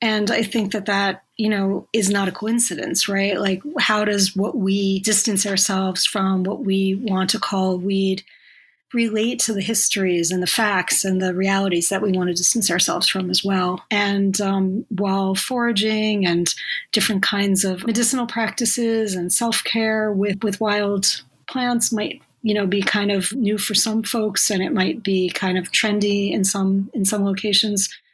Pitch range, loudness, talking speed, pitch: 190-220 Hz, -20 LUFS, 180 wpm, 200 Hz